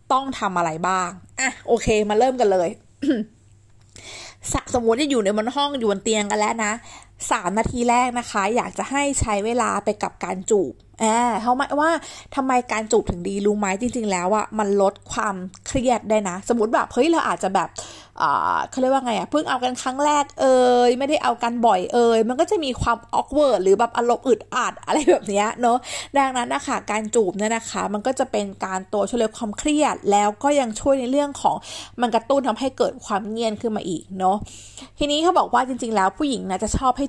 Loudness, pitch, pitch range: -21 LUFS, 235 Hz, 210-265 Hz